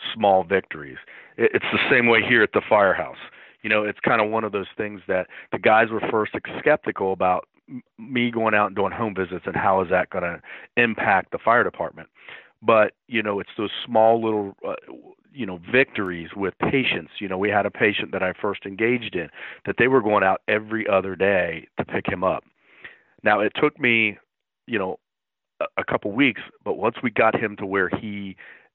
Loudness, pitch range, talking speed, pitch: -22 LUFS, 95-110 Hz, 200 wpm, 105 Hz